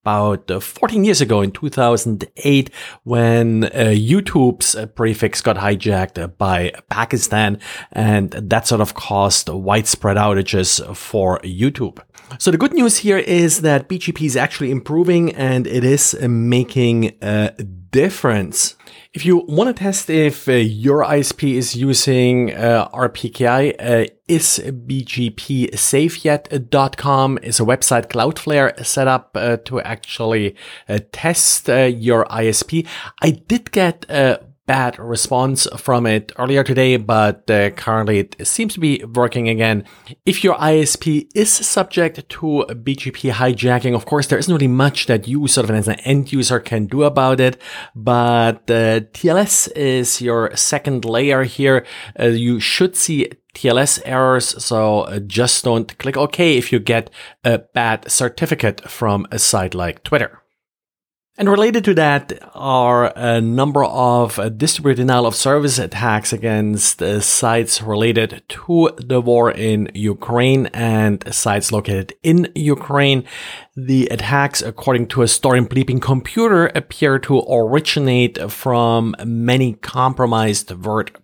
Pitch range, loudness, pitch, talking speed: 110-140 Hz, -16 LUFS, 125 Hz, 140 wpm